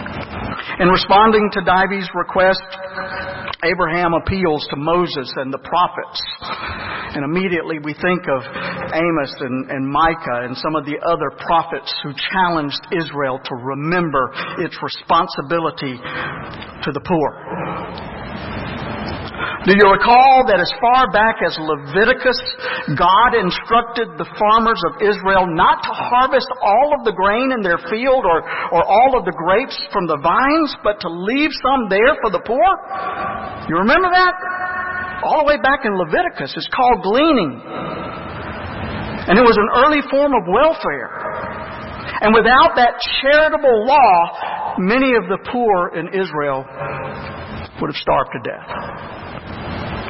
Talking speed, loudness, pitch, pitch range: 140 wpm, -16 LUFS, 195 Hz, 165-255 Hz